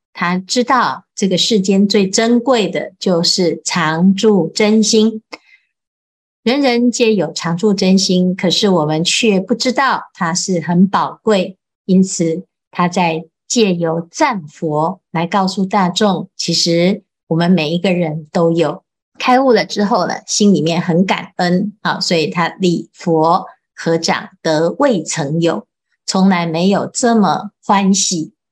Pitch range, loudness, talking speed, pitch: 170-215 Hz, -14 LUFS, 195 characters per minute, 185 Hz